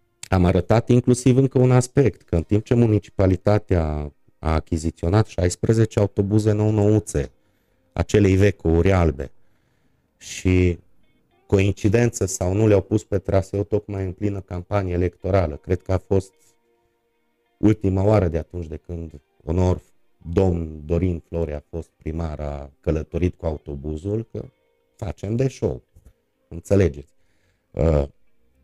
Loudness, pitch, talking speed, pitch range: -21 LUFS, 95 Hz, 130 wpm, 85-105 Hz